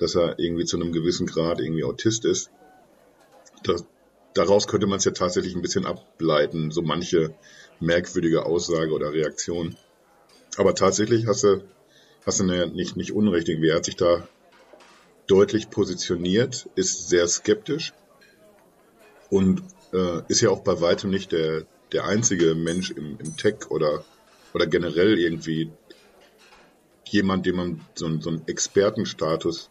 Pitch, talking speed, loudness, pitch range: 90 Hz, 145 wpm, -24 LUFS, 85-100 Hz